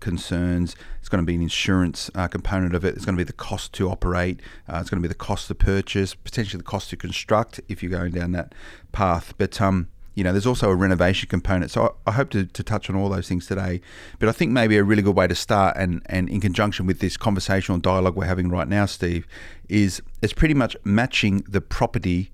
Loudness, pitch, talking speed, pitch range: -23 LUFS, 95 Hz, 240 wpm, 90-100 Hz